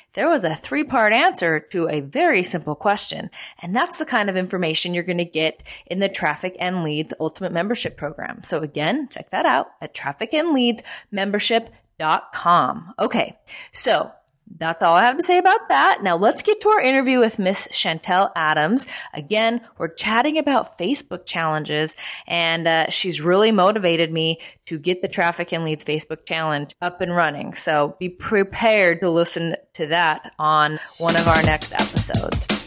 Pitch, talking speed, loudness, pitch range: 180 Hz, 170 wpm, -20 LUFS, 160-225 Hz